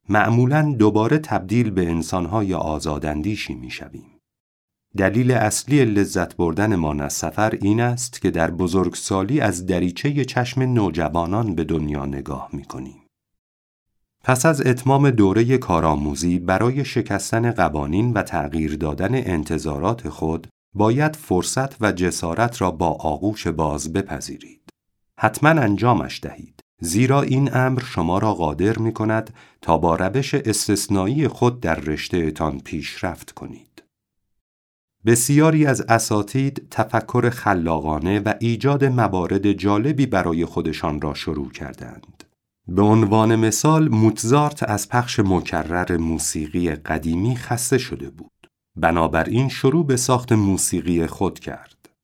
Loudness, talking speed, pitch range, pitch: -20 LUFS, 120 wpm, 80-120 Hz, 100 Hz